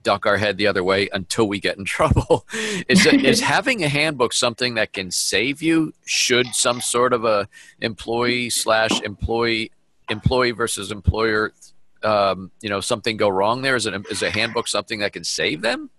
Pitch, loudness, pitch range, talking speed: 115 Hz, -20 LUFS, 100-125 Hz, 185 wpm